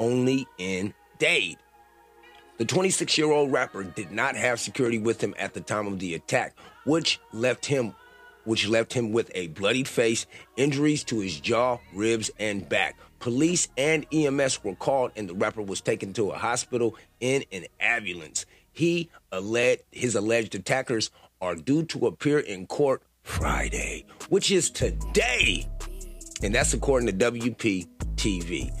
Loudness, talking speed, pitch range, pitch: -26 LUFS, 150 wpm, 105-150 Hz, 120 Hz